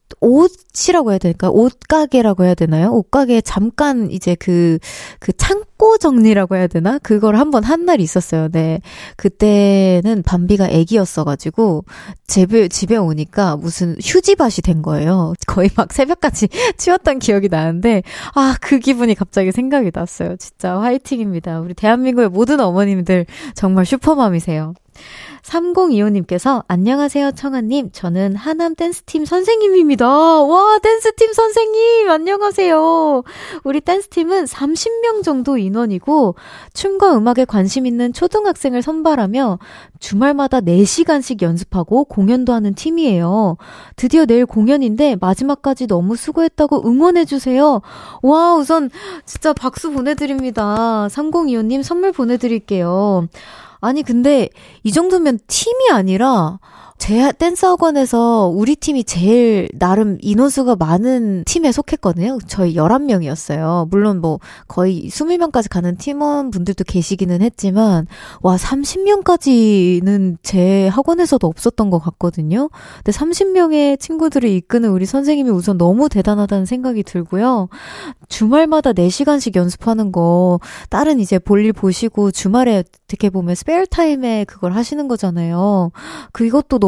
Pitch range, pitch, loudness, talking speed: 190-295 Hz, 235 Hz, -14 LUFS, 305 characters per minute